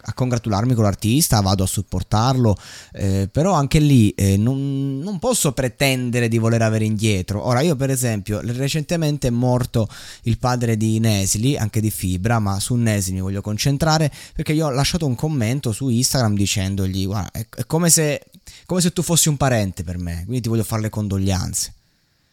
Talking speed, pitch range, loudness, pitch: 180 wpm, 105-135 Hz, -19 LUFS, 115 Hz